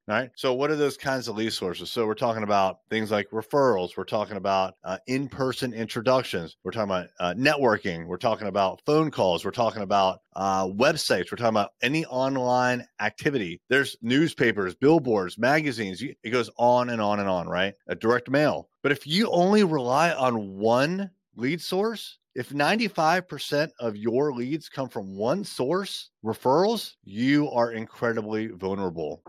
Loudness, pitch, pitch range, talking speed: -25 LUFS, 125 Hz, 110-145 Hz, 165 wpm